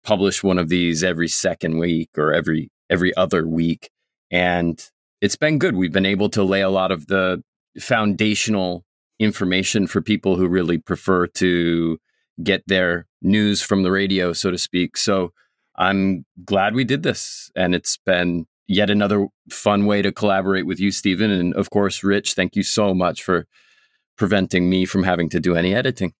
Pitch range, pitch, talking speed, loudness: 90-100 Hz, 95 Hz, 175 wpm, -20 LUFS